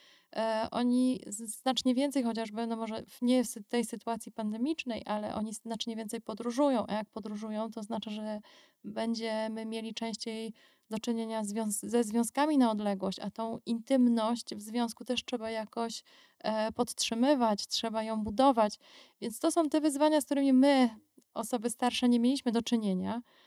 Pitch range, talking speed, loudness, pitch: 220-250 Hz, 145 wpm, -32 LUFS, 230 Hz